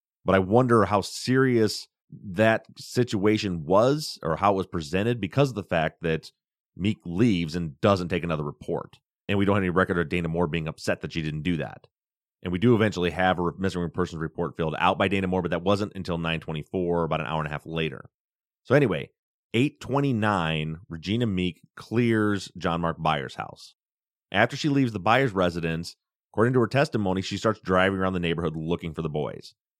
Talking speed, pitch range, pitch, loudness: 195 wpm, 85-110 Hz, 95 Hz, -25 LUFS